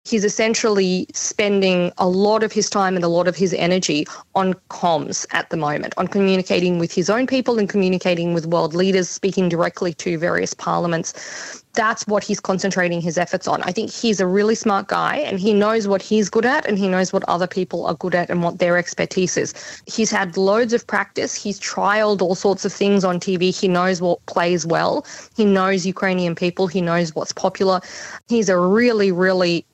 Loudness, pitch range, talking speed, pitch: -19 LUFS, 180-205 Hz, 200 wpm, 190 Hz